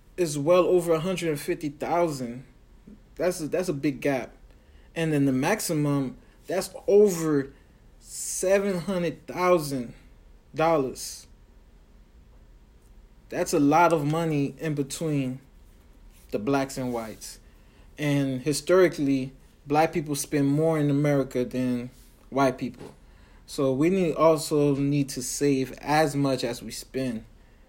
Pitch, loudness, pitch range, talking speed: 145 Hz, -25 LUFS, 130-160 Hz, 115 wpm